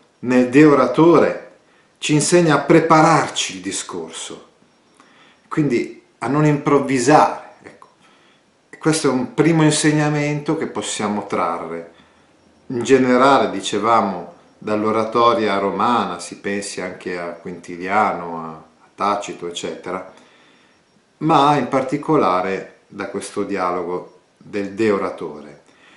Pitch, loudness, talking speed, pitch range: 125 Hz, -18 LUFS, 95 wpm, 100-150 Hz